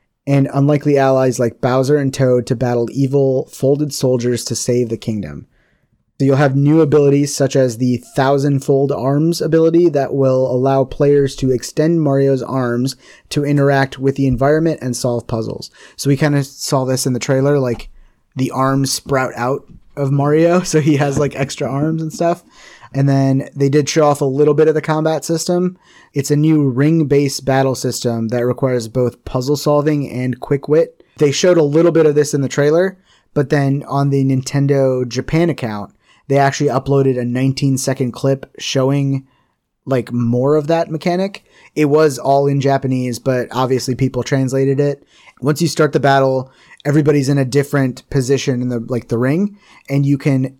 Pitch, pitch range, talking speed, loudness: 140 Hz, 130-150 Hz, 180 wpm, -16 LUFS